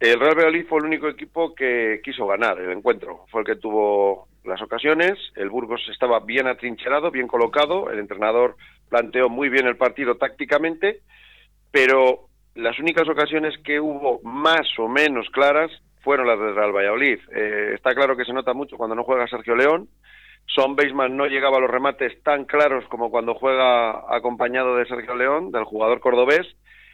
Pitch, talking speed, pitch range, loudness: 130 Hz, 175 wpm, 120-150 Hz, -21 LUFS